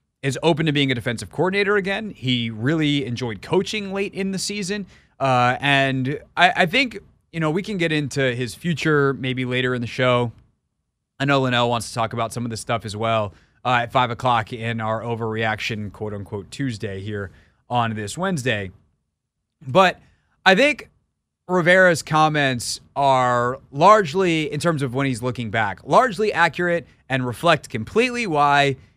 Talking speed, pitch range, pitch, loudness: 170 wpm, 120-170 Hz, 135 Hz, -20 LUFS